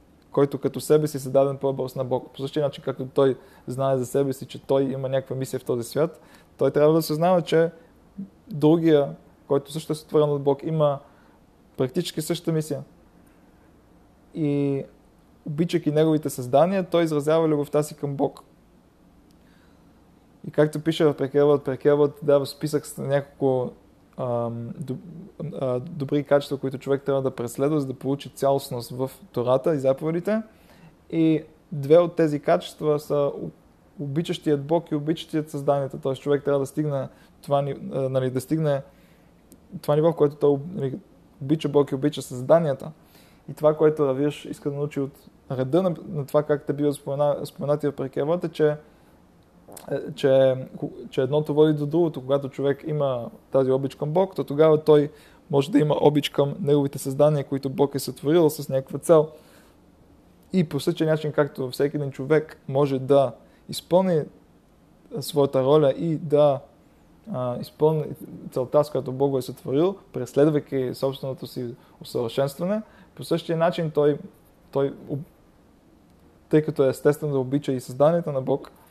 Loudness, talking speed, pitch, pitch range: -24 LUFS, 155 wpm, 145 Hz, 135-155 Hz